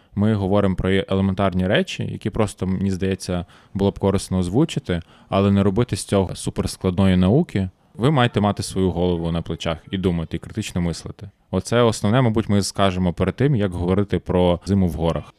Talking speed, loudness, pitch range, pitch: 175 wpm, -21 LUFS, 90-105 Hz, 95 Hz